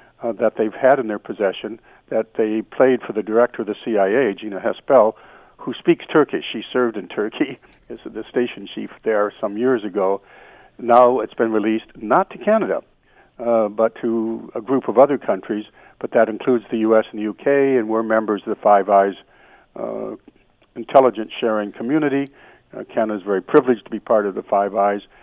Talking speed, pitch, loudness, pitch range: 190 wpm, 110 Hz, -19 LUFS, 105-125 Hz